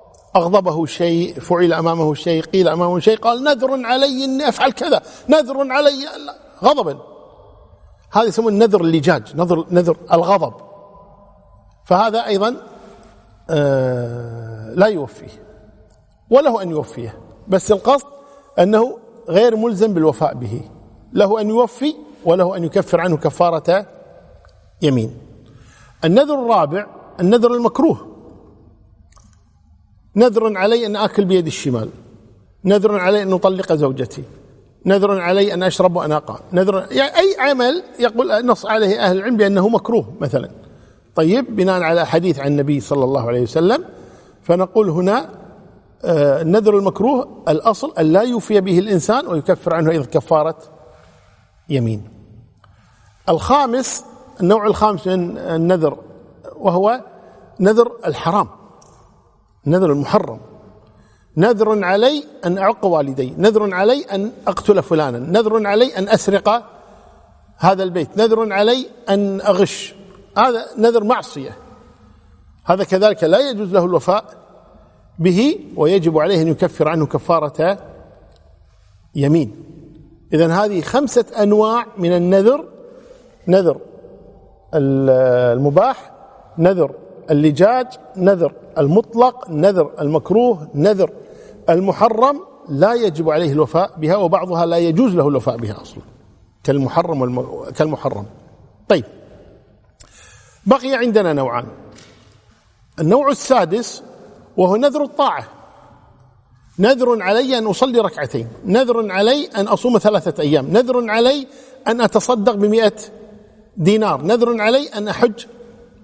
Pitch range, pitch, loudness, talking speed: 150-225 Hz, 190 Hz, -16 LUFS, 110 wpm